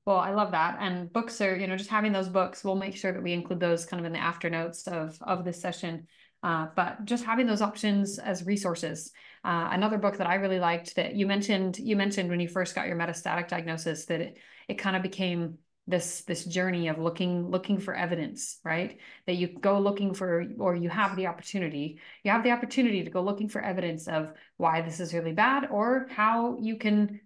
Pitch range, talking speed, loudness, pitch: 170-200 Hz, 215 wpm, -29 LUFS, 185 Hz